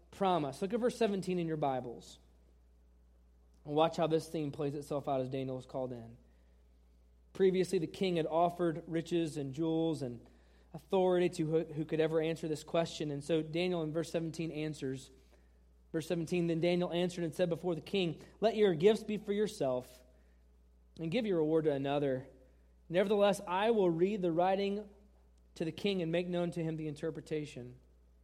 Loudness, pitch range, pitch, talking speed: -34 LUFS, 125-175 Hz, 160 Hz, 175 wpm